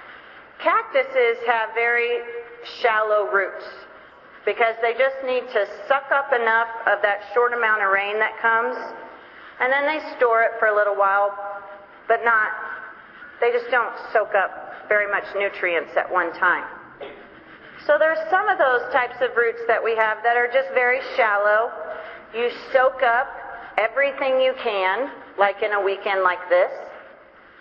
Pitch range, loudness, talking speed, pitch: 205-260 Hz, -21 LUFS, 155 wpm, 230 Hz